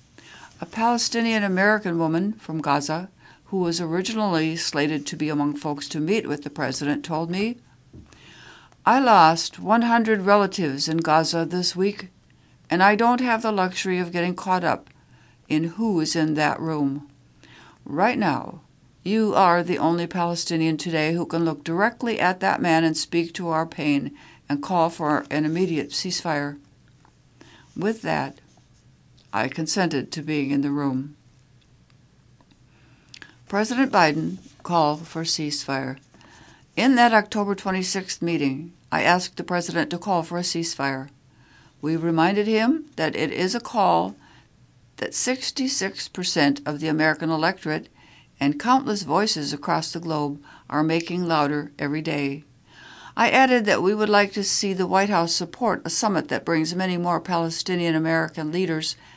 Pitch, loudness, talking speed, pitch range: 165 Hz, -23 LUFS, 150 wpm, 150-190 Hz